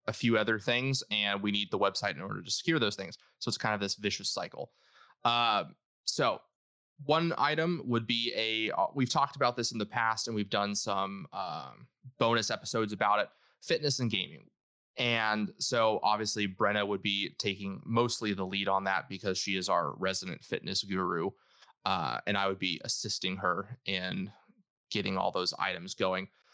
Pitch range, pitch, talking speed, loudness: 100-120 Hz, 110 Hz, 180 wpm, -31 LUFS